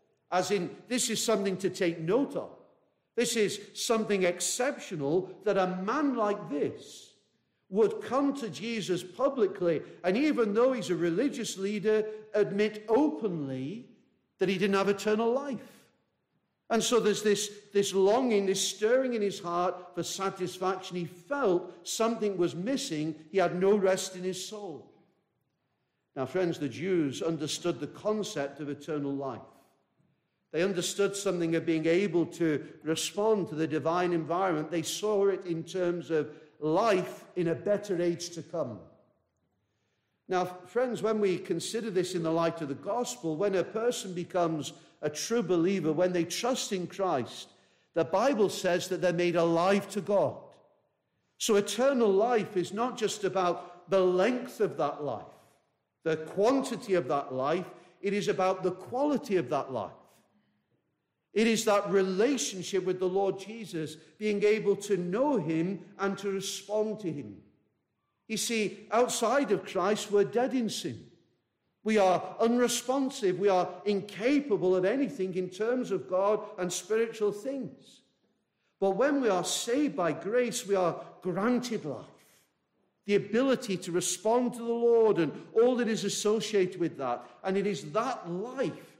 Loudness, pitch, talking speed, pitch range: -30 LUFS, 190 Hz, 155 wpm, 175-215 Hz